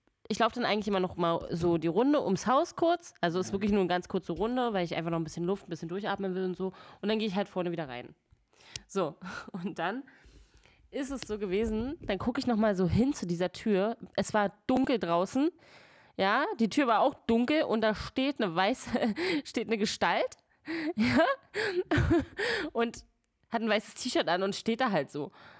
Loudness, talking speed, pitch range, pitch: -30 LUFS, 210 wpm, 185-255 Hz, 215 Hz